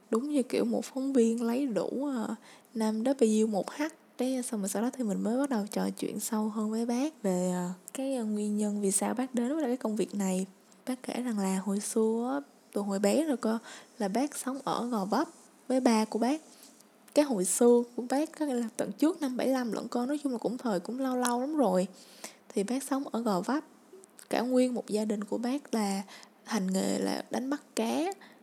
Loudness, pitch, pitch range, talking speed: -31 LUFS, 240 Hz, 210-265 Hz, 225 wpm